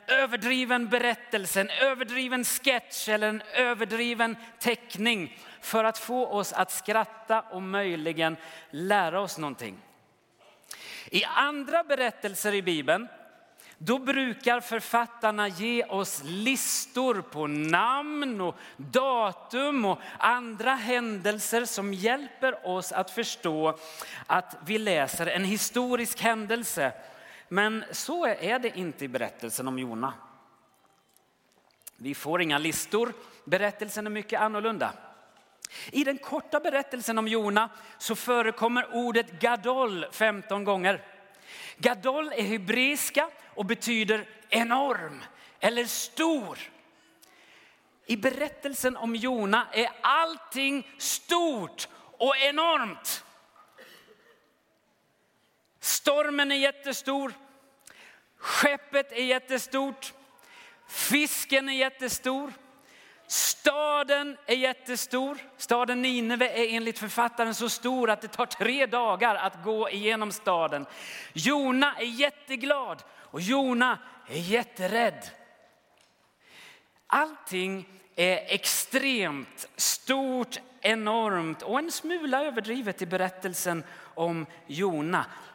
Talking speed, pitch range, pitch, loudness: 100 wpm, 205-265 Hz, 235 Hz, -28 LUFS